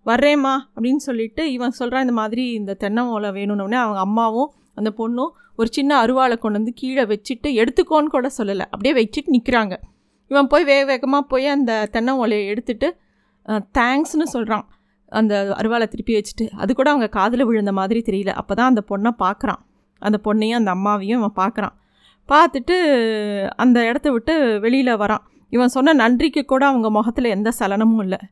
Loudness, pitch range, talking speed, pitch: -19 LUFS, 215-270 Hz, 160 wpm, 235 Hz